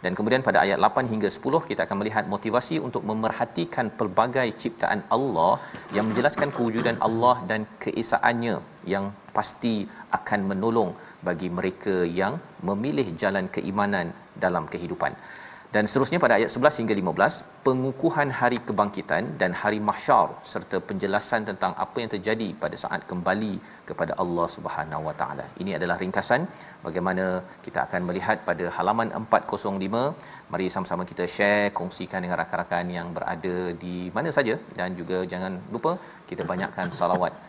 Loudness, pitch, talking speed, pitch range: -26 LUFS, 105 Hz, 145 wpm, 90-115 Hz